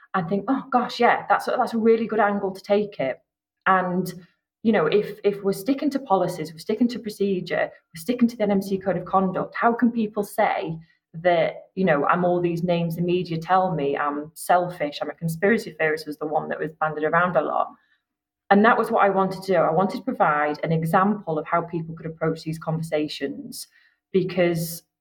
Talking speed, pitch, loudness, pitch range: 210 wpm, 190 Hz, -23 LUFS, 160-210 Hz